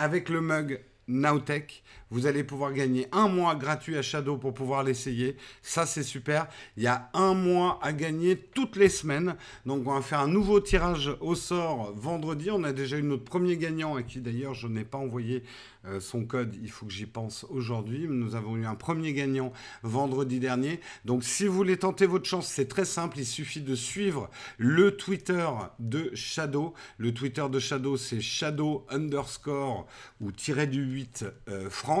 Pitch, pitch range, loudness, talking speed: 140 Hz, 125-165 Hz, -30 LUFS, 185 wpm